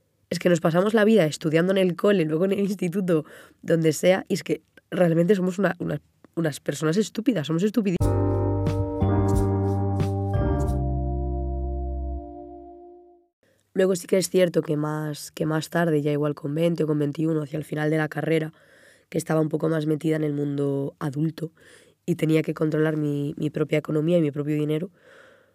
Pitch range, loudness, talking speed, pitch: 145-180 Hz, -24 LUFS, 170 wpm, 155 Hz